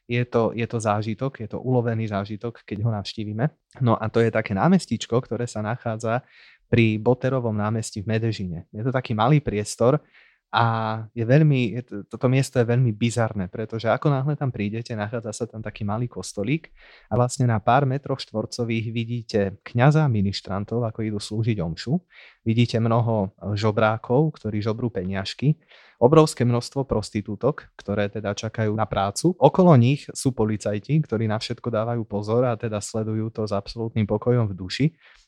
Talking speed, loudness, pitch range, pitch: 160 wpm, -24 LUFS, 105-125 Hz, 115 Hz